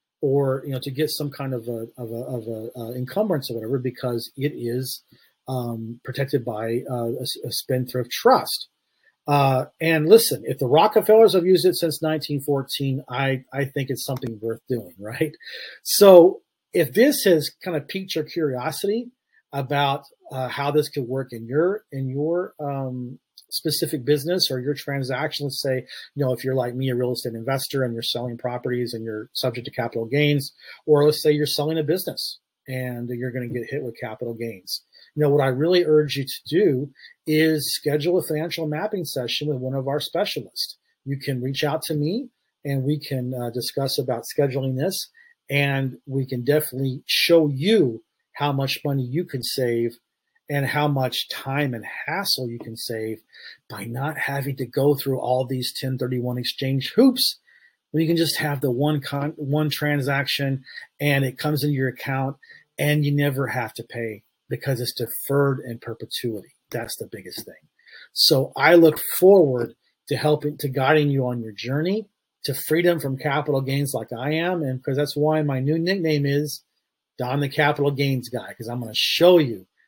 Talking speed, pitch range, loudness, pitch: 185 wpm, 125-150 Hz, -23 LUFS, 140 Hz